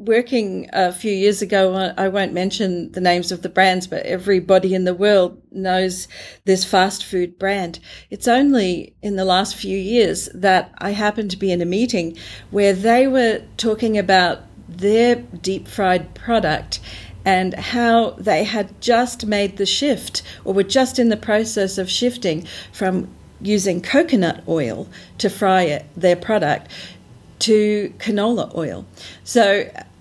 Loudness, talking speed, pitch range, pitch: -18 LUFS, 150 wpm, 185-215 Hz, 195 Hz